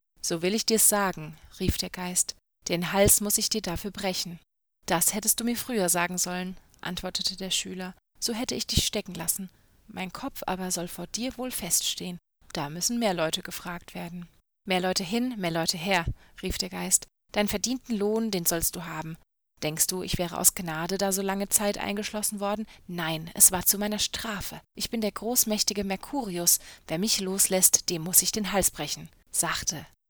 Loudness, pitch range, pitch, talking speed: -26 LUFS, 175-210 Hz, 185 Hz, 185 wpm